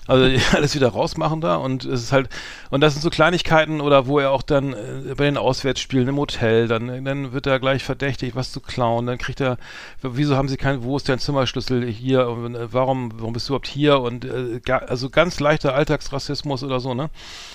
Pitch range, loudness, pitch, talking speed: 125-140 Hz, -21 LUFS, 135 Hz, 205 wpm